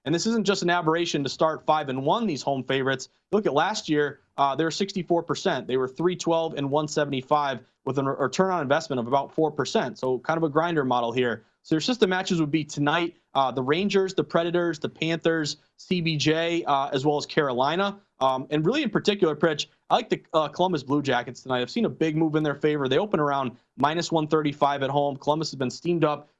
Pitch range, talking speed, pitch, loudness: 140-170 Hz, 220 wpm, 155 Hz, -25 LUFS